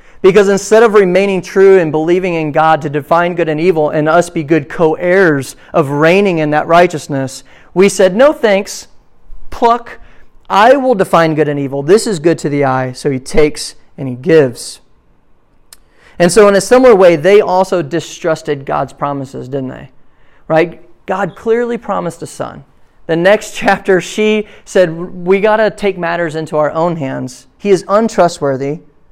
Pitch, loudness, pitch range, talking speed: 170 Hz, -11 LUFS, 150-195 Hz, 175 wpm